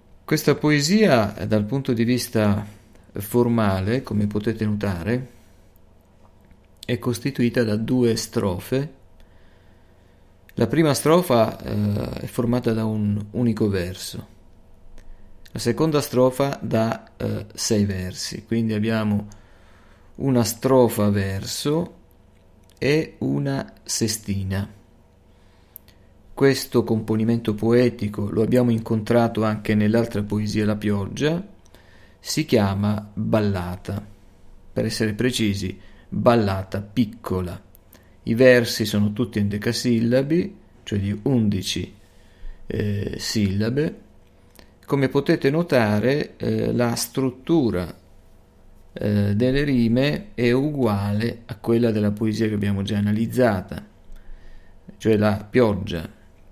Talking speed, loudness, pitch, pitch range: 95 wpm, -22 LUFS, 105 Hz, 95-120 Hz